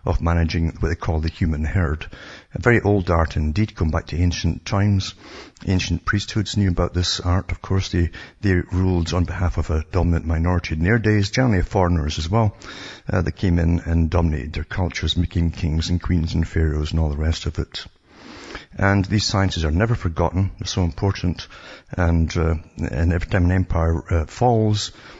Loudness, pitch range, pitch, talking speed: -21 LUFS, 80-100 Hz, 90 Hz, 190 wpm